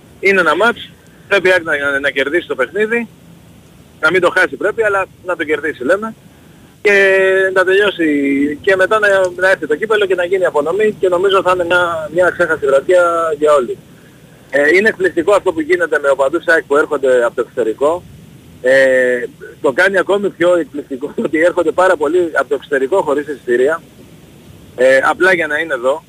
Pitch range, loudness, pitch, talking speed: 155-215 Hz, -13 LUFS, 185 Hz, 180 wpm